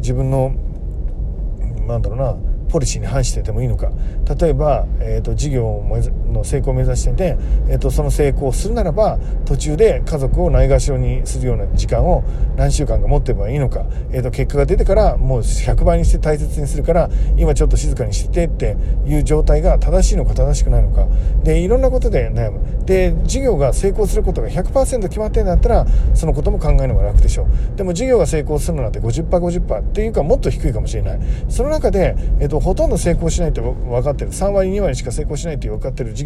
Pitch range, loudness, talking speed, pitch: 110-150 Hz, -18 LUFS, 420 characters per minute, 130 Hz